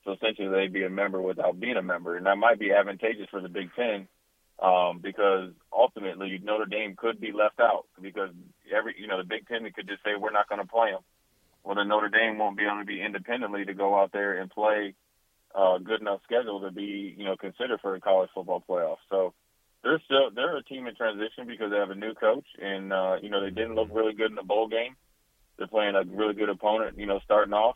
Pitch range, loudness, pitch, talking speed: 95-110 Hz, -28 LUFS, 100 Hz, 240 wpm